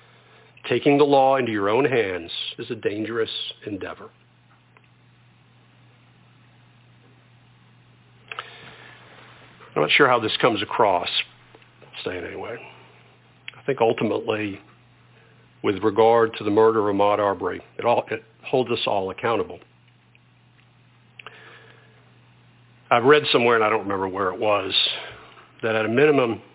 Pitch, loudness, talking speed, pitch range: 110 Hz, -21 LUFS, 120 wpm, 100-120 Hz